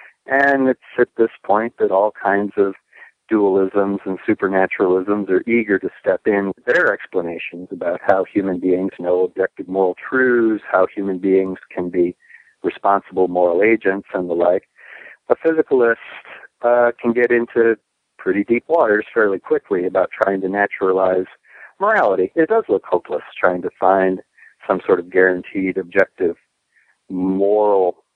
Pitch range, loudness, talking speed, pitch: 95-115 Hz, -18 LUFS, 145 wpm, 95 Hz